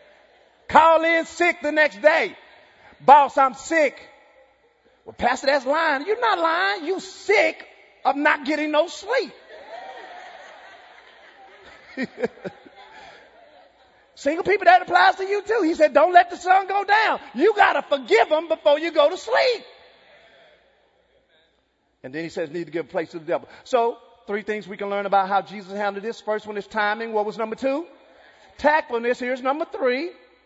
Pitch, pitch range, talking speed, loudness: 295 Hz, 230-350 Hz, 165 wpm, -21 LUFS